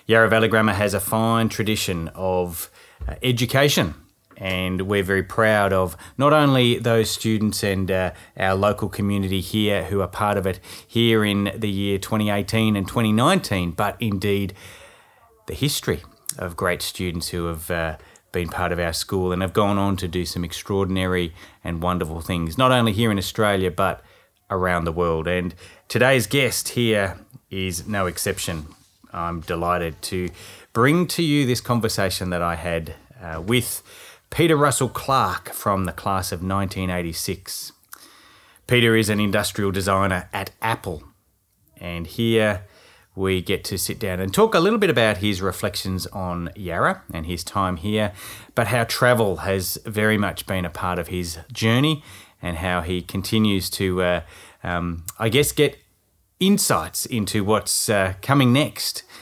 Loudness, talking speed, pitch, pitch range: -22 LUFS, 160 wpm, 100 Hz, 90-110 Hz